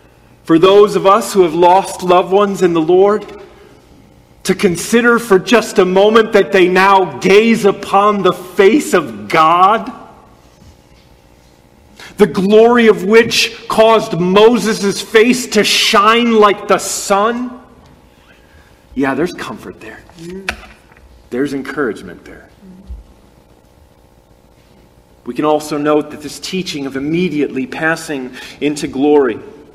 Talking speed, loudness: 115 wpm, -12 LUFS